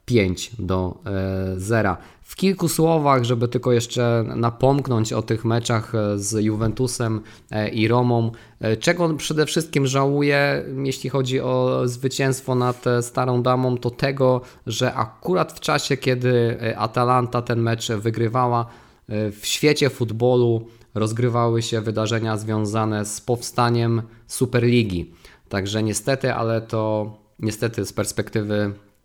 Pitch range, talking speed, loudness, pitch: 110-125 Hz, 120 wpm, -22 LUFS, 120 Hz